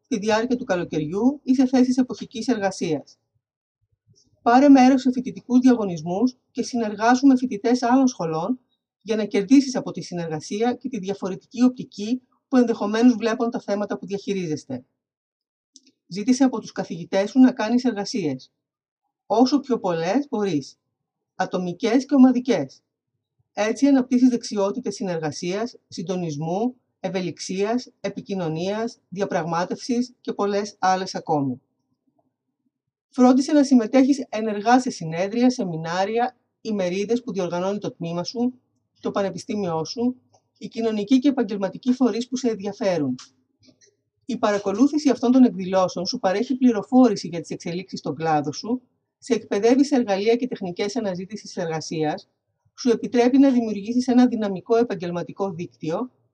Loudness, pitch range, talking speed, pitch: -22 LUFS, 185-250 Hz, 125 wpm, 215 Hz